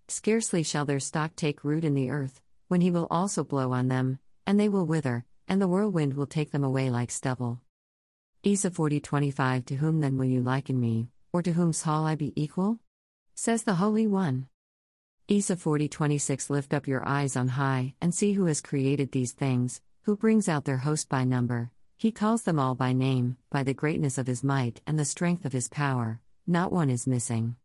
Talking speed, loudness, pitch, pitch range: 200 wpm, -28 LUFS, 140 Hz, 130-170 Hz